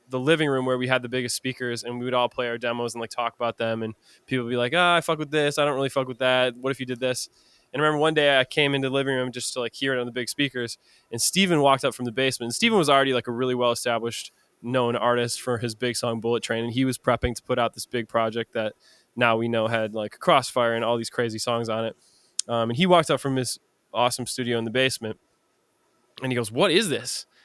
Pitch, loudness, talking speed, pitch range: 125 Hz, -24 LUFS, 280 wpm, 120-130 Hz